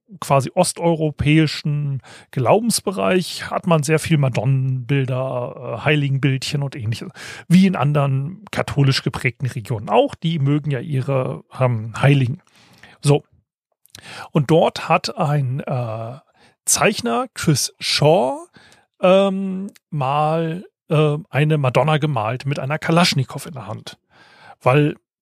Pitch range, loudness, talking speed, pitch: 130-165 Hz, -19 LUFS, 110 wpm, 145 Hz